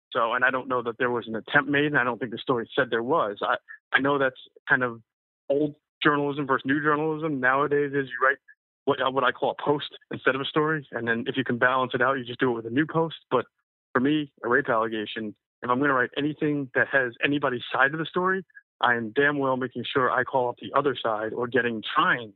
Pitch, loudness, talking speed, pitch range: 135 Hz, -25 LUFS, 255 wpm, 125-150 Hz